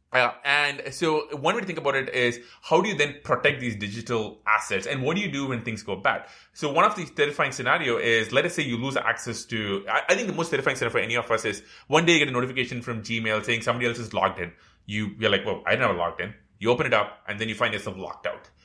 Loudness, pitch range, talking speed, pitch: -25 LUFS, 110-145 Hz, 275 wpm, 120 Hz